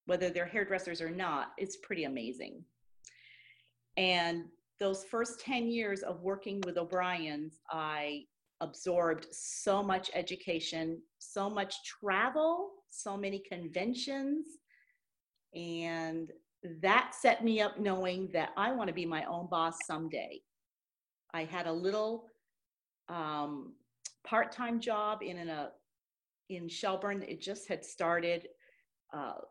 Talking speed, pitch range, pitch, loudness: 120 wpm, 170-210 Hz, 185 Hz, -35 LUFS